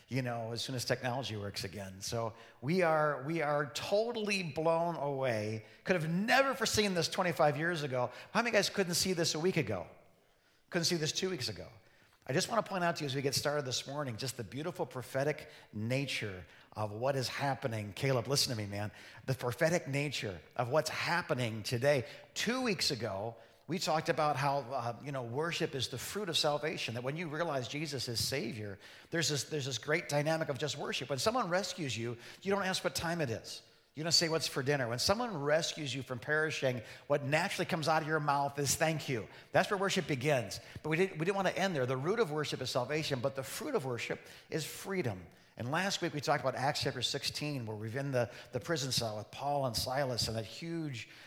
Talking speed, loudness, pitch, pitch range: 220 wpm, -34 LUFS, 145 Hz, 125-165 Hz